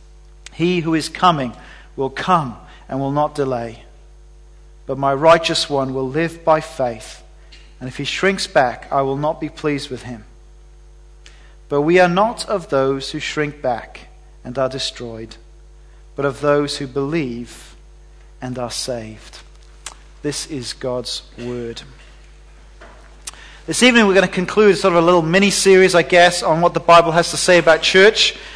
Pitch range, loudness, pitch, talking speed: 120-170 Hz, -16 LUFS, 140 Hz, 160 wpm